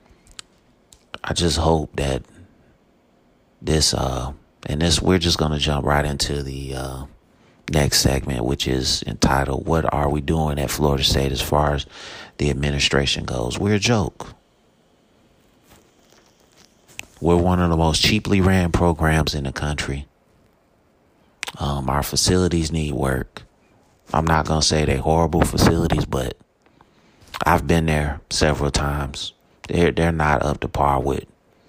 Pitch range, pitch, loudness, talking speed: 70-80 Hz, 75 Hz, -20 LUFS, 140 wpm